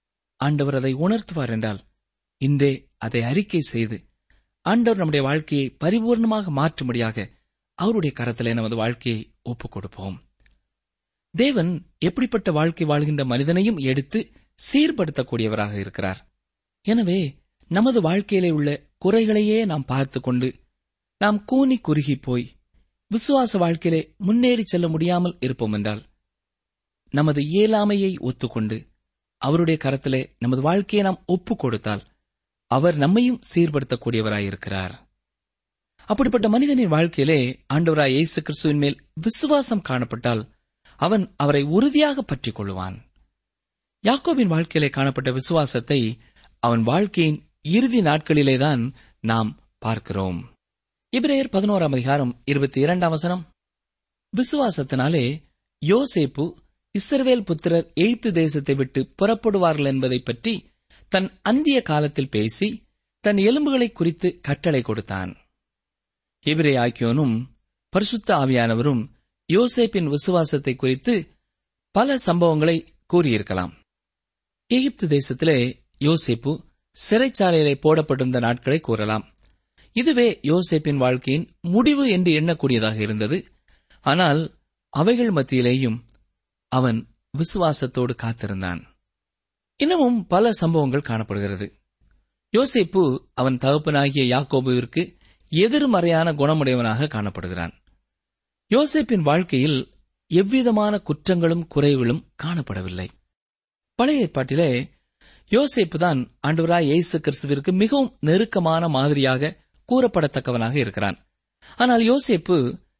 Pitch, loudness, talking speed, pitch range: 150 Hz, -21 LUFS, 90 wpm, 120-190 Hz